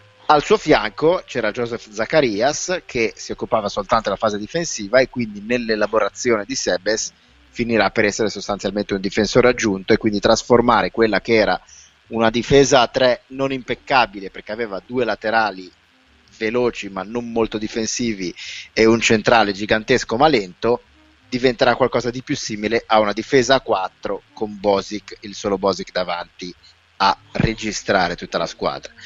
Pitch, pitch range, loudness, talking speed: 110 Hz, 100-120 Hz, -19 LUFS, 150 wpm